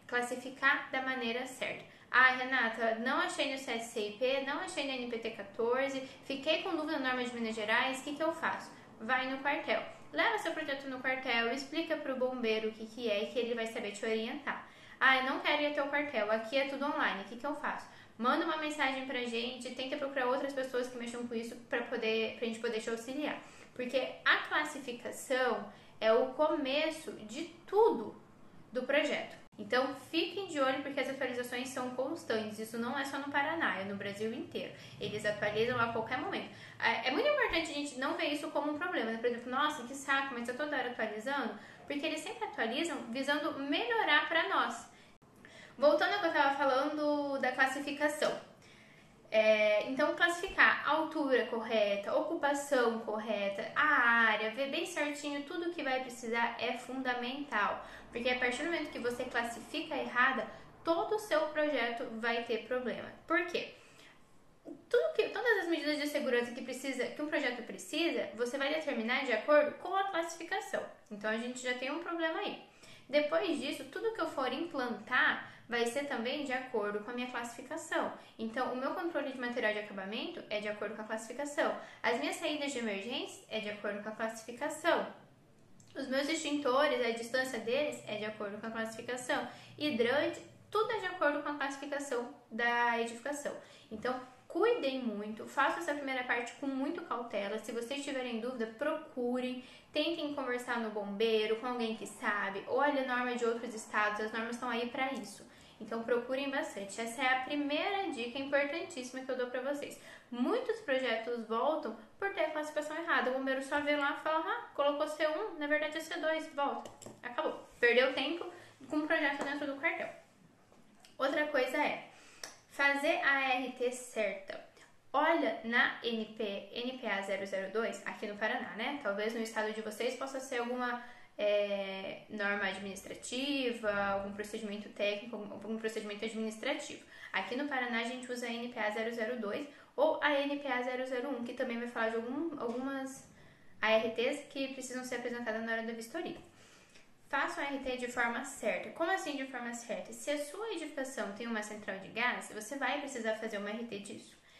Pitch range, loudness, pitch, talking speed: 230-295 Hz, -35 LUFS, 260 Hz, 180 wpm